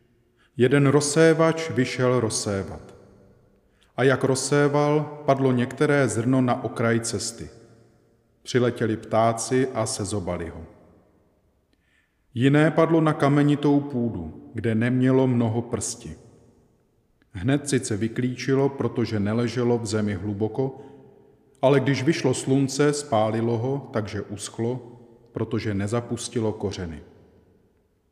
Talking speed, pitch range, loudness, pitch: 100 wpm, 105-135 Hz, -23 LUFS, 120 Hz